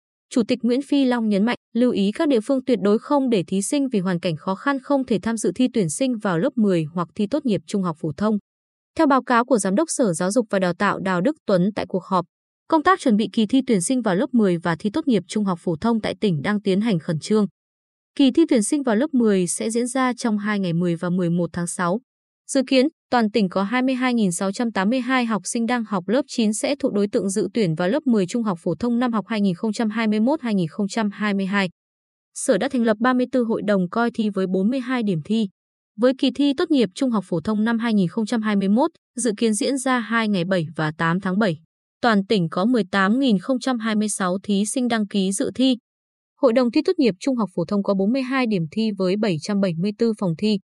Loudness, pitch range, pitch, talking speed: -21 LUFS, 195-255 Hz, 220 Hz, 230 wpm